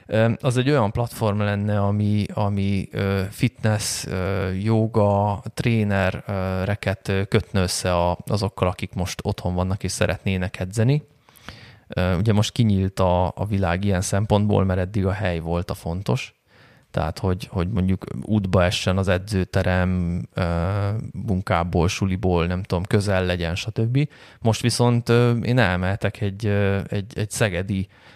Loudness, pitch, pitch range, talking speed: -22 LUFS, 100 Hz, 90-105 Hz, 125 wpm